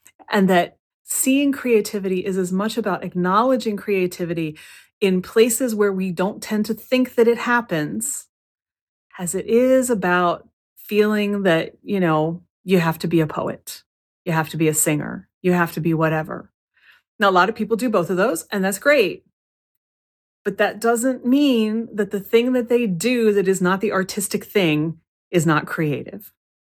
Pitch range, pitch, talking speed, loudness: 175-225 Hz, 200 Hz, 175 wpm, -20 LUFS